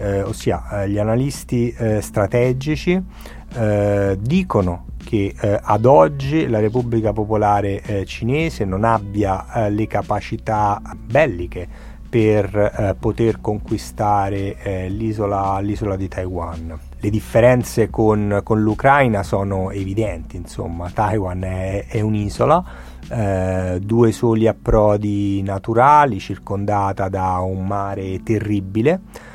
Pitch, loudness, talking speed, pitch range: 105 Hz, -19 LUFS, 110 wpm, 95-115 Hz